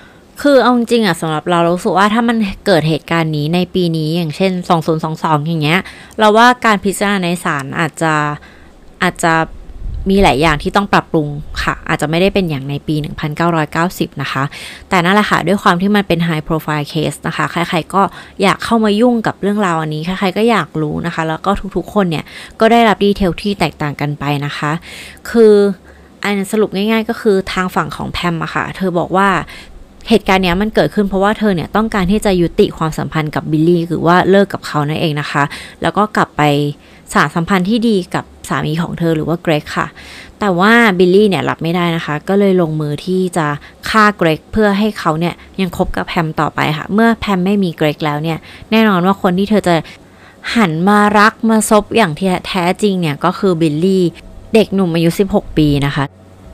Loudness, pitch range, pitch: -14 LUFS, 160-200 Hz, 180 Hz